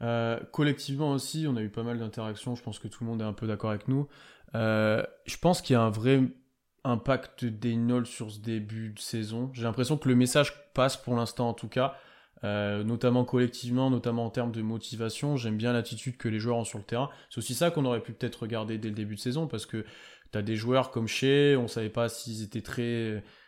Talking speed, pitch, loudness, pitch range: 240 wpm, 120 Hz, -30 LUFS, 110-130 Hz